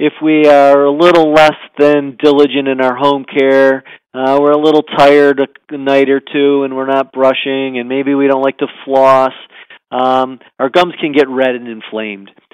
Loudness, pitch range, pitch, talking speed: -11 LUFS, 130-145 Hz, 135 Hz, 190 wpm